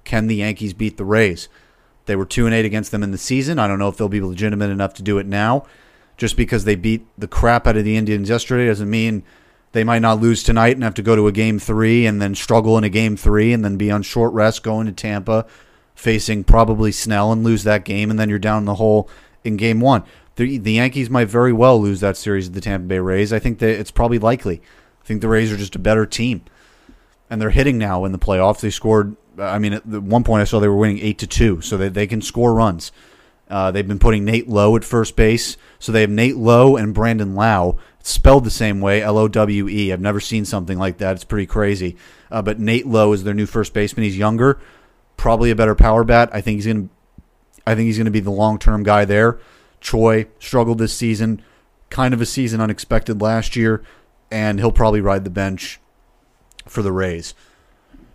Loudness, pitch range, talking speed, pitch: -17 LUFS, 105-115 Hz, 235 wpm, 110 Hz